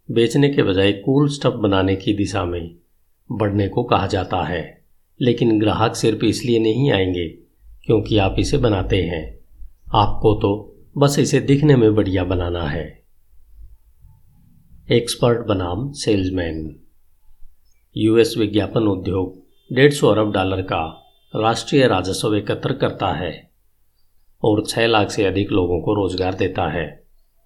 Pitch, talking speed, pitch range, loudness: 105 Hz, 130 wpm, 90-115 Hz, -19 LUFS